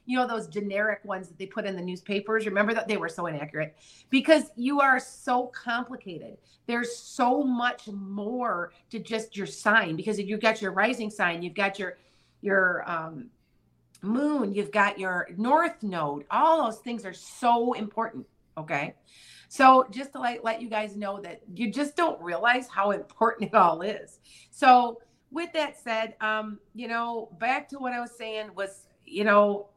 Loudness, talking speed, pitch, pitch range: -27 LUFS, 180 wpm, 220 Hz, 195-245 Hz